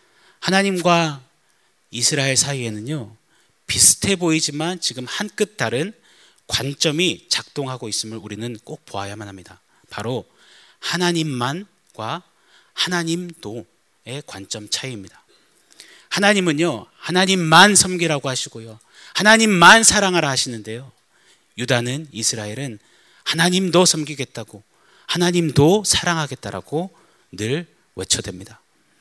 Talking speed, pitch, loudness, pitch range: 270 characters per minute, 150 Hz, -18 LUFS, 115-175 Hz